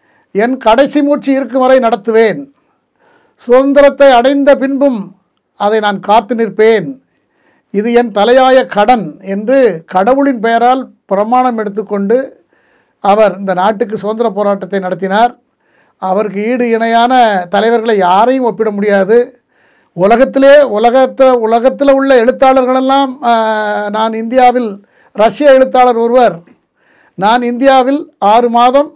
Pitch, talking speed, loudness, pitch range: 240 Hz, 100 wpm, -9 LUFS, 215-265 Hz